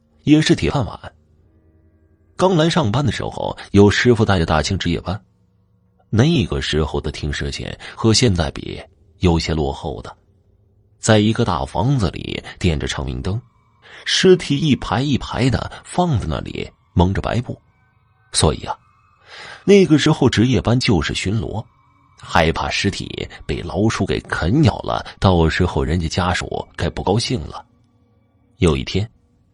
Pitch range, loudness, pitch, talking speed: 80-115 Hz, -18 LUFS, 100 Hz, 215 characters per minute